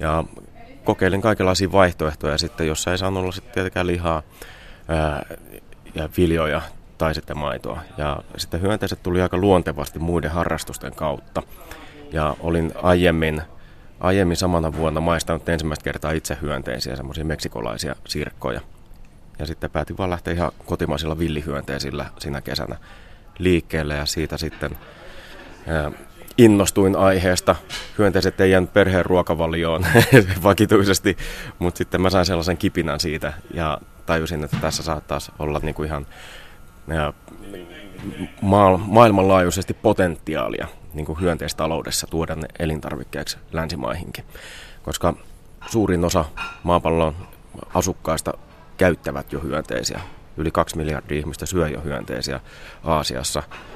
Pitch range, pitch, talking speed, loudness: 75-90 Hz, 80 Hz, 115 wpm, -21 LUFS